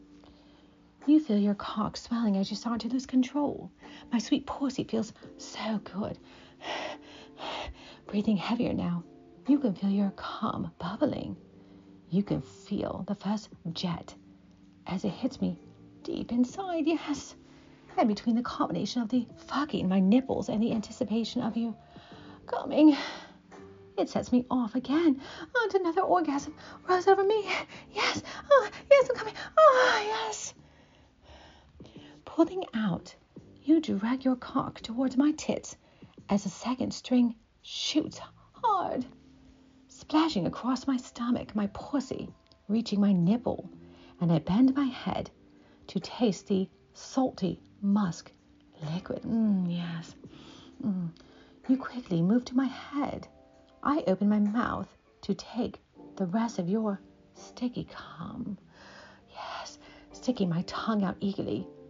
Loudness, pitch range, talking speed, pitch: -30 LUFS, 195-270 Hz, 130 wpm, 230 Hz